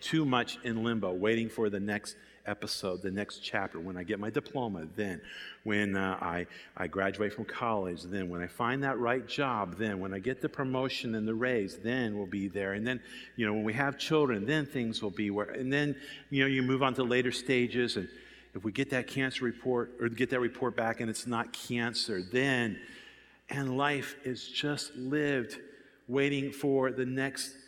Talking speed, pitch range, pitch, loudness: 205 wpm, 110-135 Hz, 120 Hz, -33 LUFS